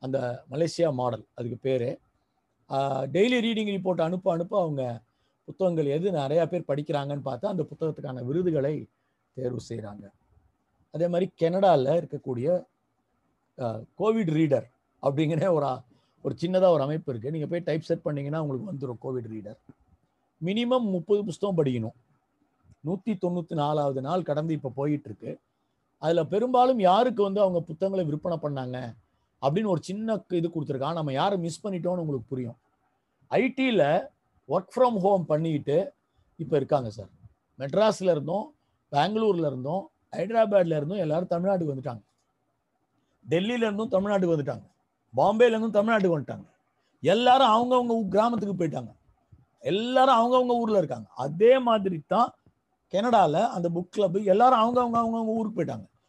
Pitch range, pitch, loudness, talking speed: 140-200 Hz, 165 Hz, -26 LUFS, 125 wpm